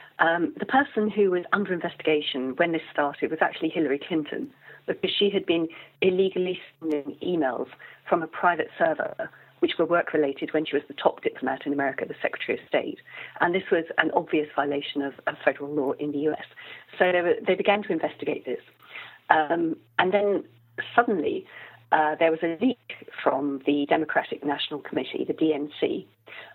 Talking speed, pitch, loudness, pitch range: 175 wpm, 165 Hz, -26 LUFS, 145-200 Hz